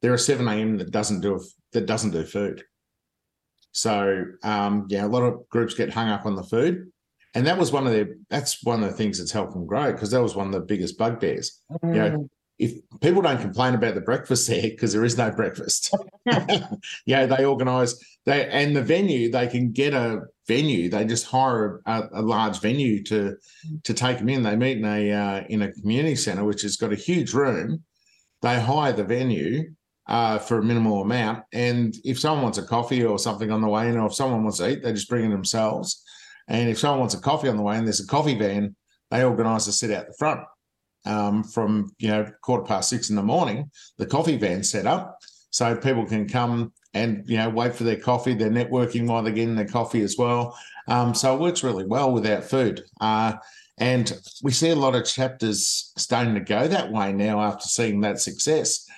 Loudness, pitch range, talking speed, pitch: -24 LUFS, 105-125 Hz, 220 wpm, 115 Hz